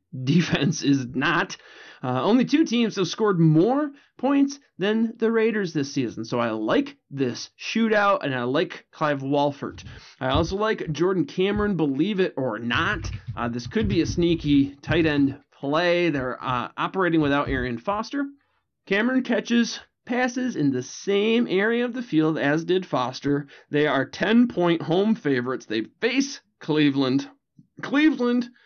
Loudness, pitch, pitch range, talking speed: -23 LUFS, 170 Hz, 140-225 Hz, 155 wpm